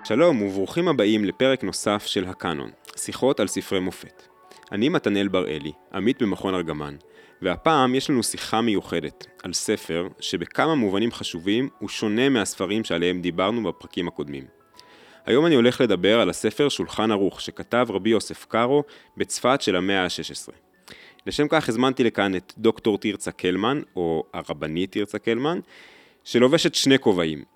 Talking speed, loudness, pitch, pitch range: 140 wpm, -23 LUFS, 100 Hz, 85-120 Hz